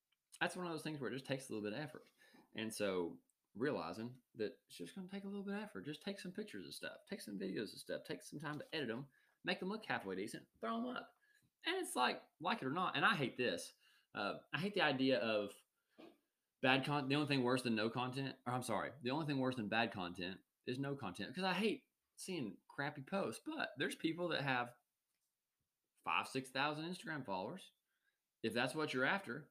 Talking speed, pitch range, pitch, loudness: 230 wpm, 120-185 Hz, 140 Hz, -42 LUFS